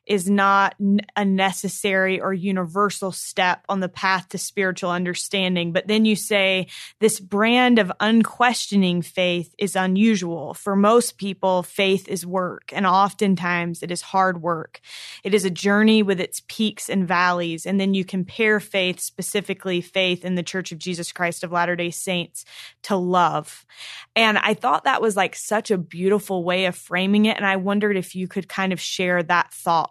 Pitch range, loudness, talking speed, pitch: 180-205 Hz, -21 LUFS, 175 wpm, 190 Hz